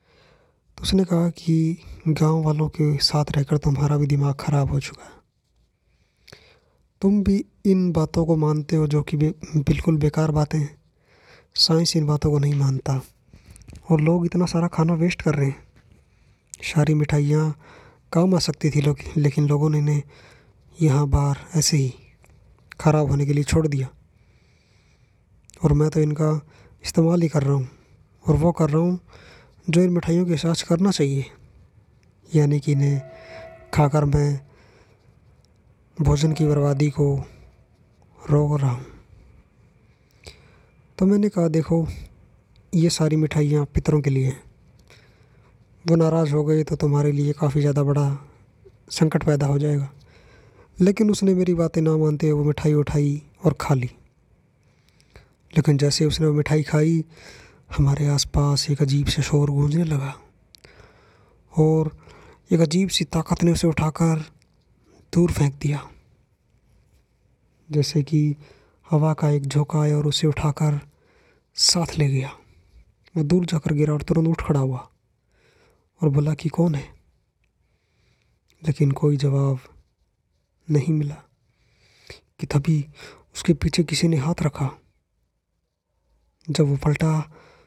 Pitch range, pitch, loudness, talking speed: 140-160 Hz, 150 Hz, -21 LUFS, 140 wpm